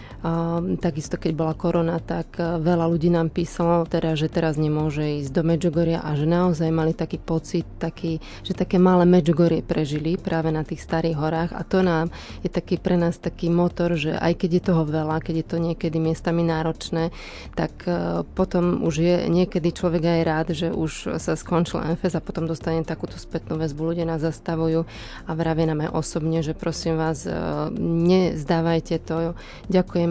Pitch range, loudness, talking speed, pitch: 160-175 Hz, -23 LUFS, 180 wpm, 165 Hz